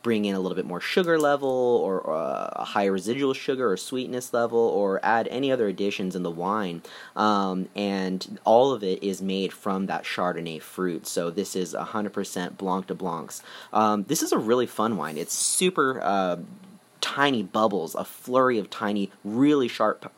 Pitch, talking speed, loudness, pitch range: 100 Hz, 180 wpm, -25 LUFS, 95-125 Hz